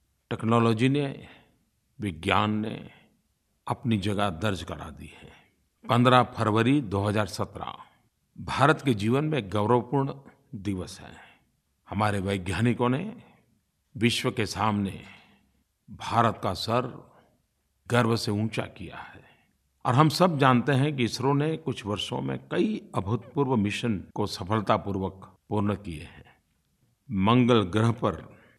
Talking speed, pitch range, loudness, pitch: 120 wpm, 95-125 Hz, -26 LUFS, 110 Hz